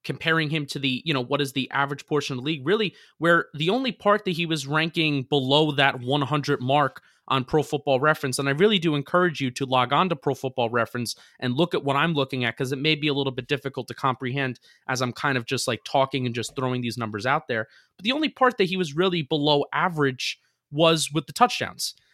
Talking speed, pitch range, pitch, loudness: 240 wpm, 130-160 Hz, 145 Hz, -24 LUFS